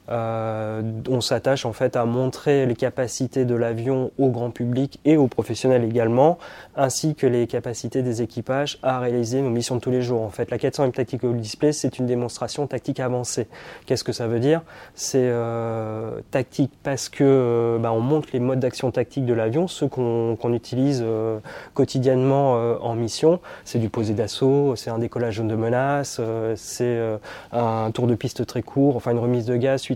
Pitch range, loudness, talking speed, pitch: 115-135 Hz, -23 LUFS, 190 wpm, 125 Hz